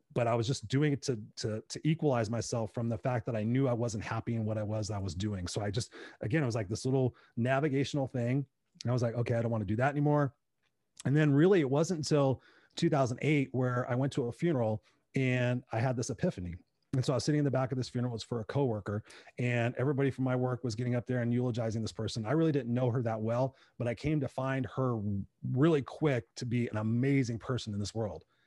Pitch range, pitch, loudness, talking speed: 115-135 Hz, 125 Hz, -32 LUFS, 255 wpm